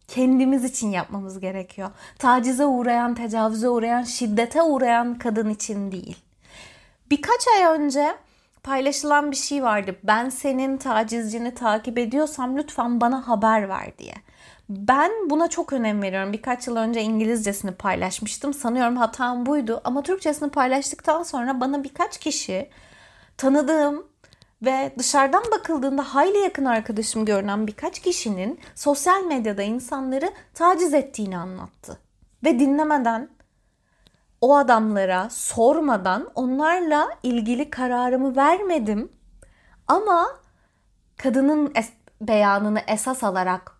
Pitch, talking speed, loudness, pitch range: 255 Hz, 110 wpm, -22 LUFS, 220-290 Hz